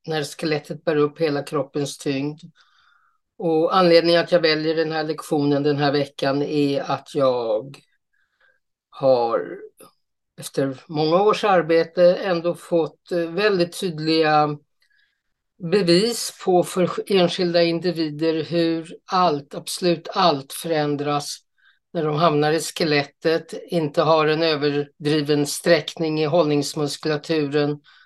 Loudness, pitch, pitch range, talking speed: -21 LUFS, 160 Hz, 150-175 Hz, 110 wpm